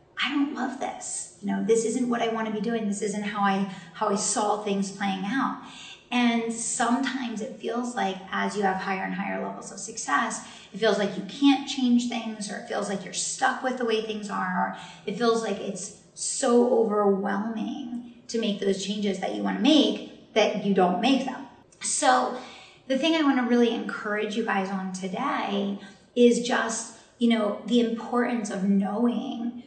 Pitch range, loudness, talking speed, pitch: 200-245 Hz, -26 LUFS, 195 wpm, 225 Hz